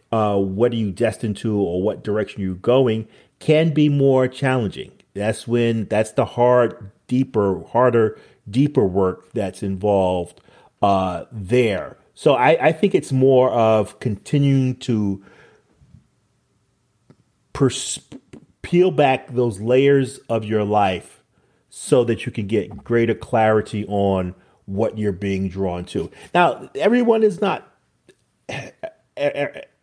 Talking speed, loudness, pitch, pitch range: 125 wpm, -20 LUFS, 115 Hz, 105-130 Hz